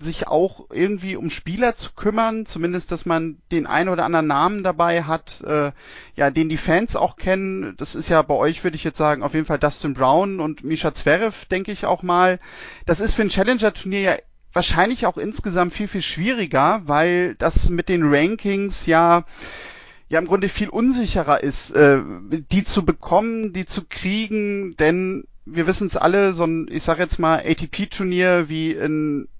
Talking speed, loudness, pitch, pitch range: 185 wpm, -20 LUFS, 180 Hz, 160-195 Hz